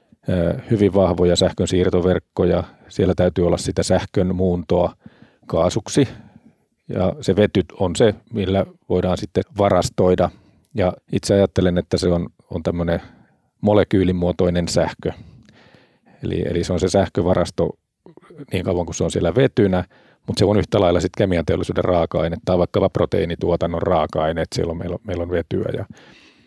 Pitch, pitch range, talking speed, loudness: 90 Hz, 85-95 Hz, 145 wpm, -20 LUFS